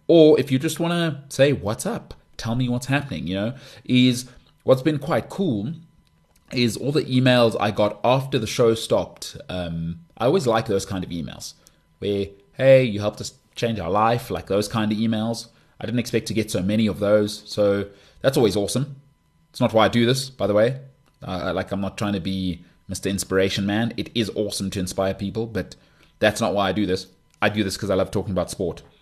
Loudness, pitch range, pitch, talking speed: -22 LUFS, 100-125 Hz, 110 Hz, 215 wpm